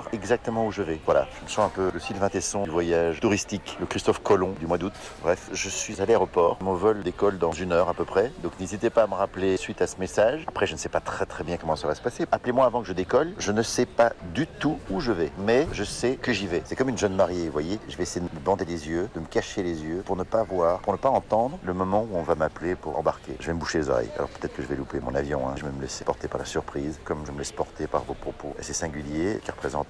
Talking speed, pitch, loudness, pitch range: 305 wpm, 90 Hz, -27 LUFS, 80-100 Hz